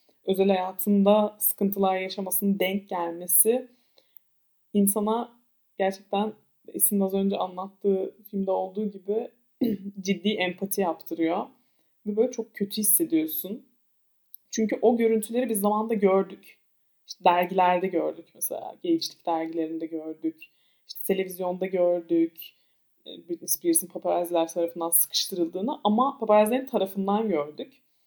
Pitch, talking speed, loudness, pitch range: 195 Hz, 105 wpm, -26 LUFS, 180-215 Hz